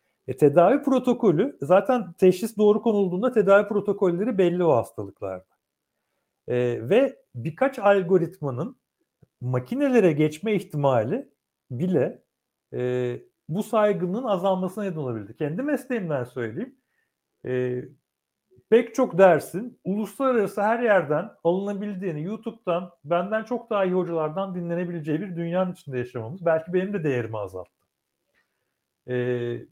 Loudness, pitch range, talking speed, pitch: -24 LUFS, 145-210 Hz, 105 wpm, 185 Hz